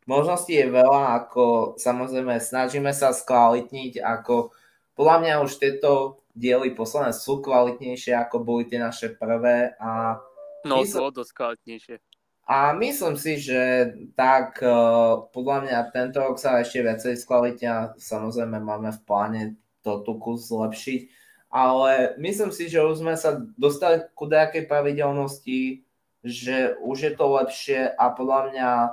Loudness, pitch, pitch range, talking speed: -23 LUFS, 125 Hz, 120-140 Hz, 140 wpm